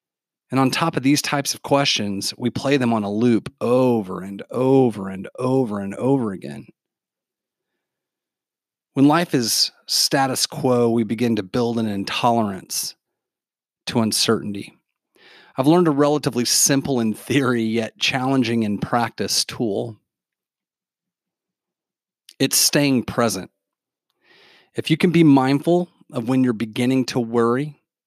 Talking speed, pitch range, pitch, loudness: 130 wpm, 115-140 Hz, 125 Hz, -20 LUFS